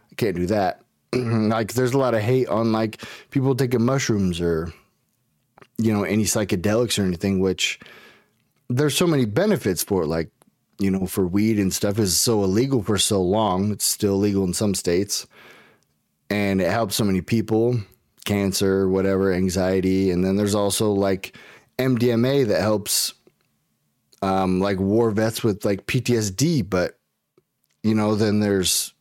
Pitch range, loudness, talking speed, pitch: 95-115 Hz, -21 LUFS, 155 wpm, 105 Hz